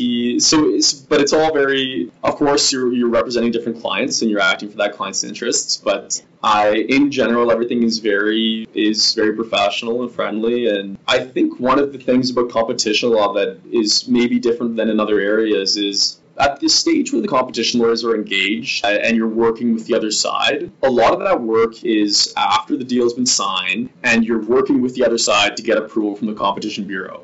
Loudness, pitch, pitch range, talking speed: -17 LUFS, 115 Hz, 110-130 Hz, 205 wpm